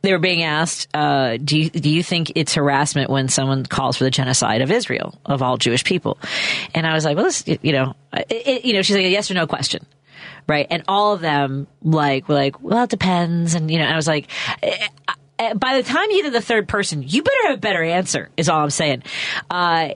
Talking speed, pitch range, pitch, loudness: 245 wpm, 140-190 Hz, 160 Hz, -19 LUFS